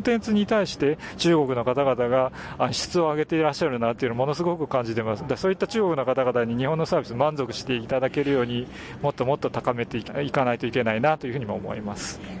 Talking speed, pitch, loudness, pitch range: 515 characters per minute, 130 Hz, -25 LUFS, 120-155 Hz